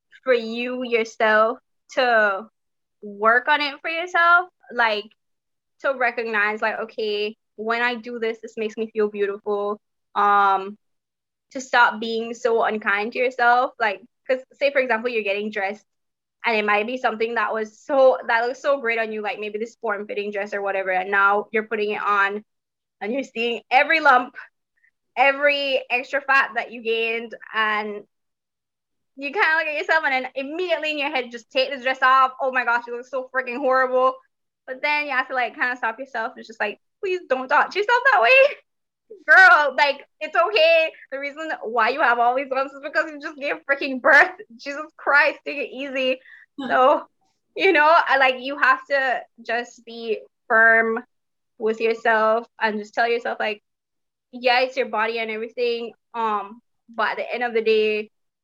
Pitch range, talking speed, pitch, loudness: 220-275 Hz, 185 wpm, 240 Hz, -21 LUFS